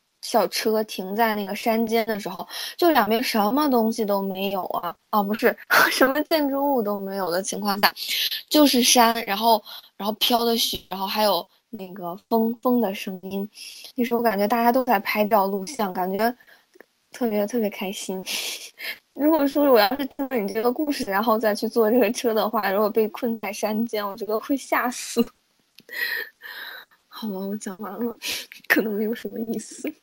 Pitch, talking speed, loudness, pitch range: 225 Hz, 260 characters per minute, -23 LUFS, 205-250 Hz